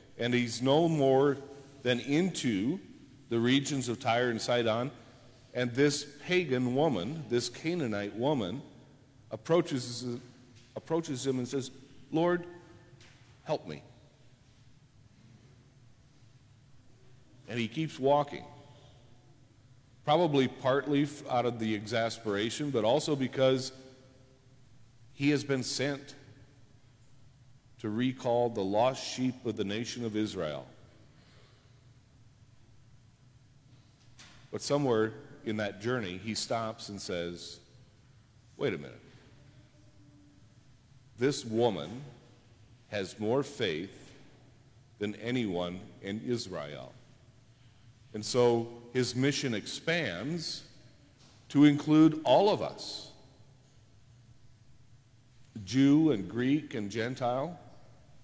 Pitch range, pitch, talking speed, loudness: 115-135 Hz, 125 Hz, 95 wpm, -31 LUFS